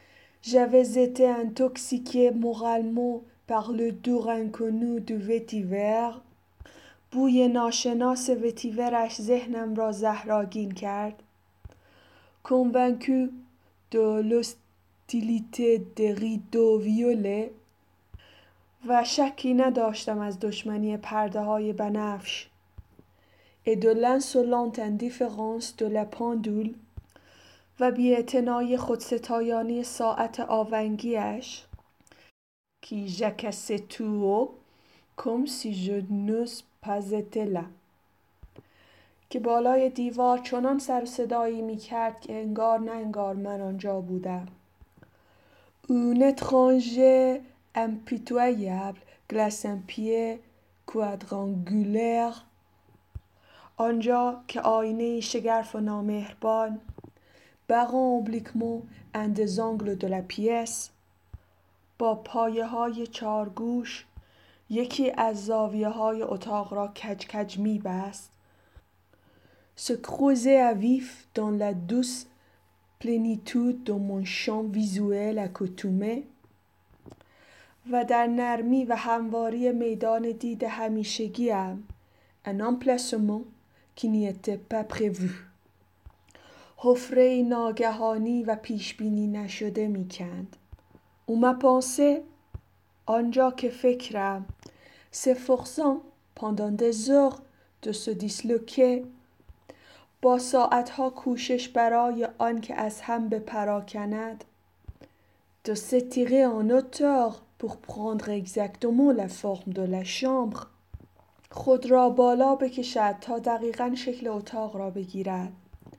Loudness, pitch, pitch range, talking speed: -27 LUFS, 225 Hz, 205-245 Hz, 85 wpm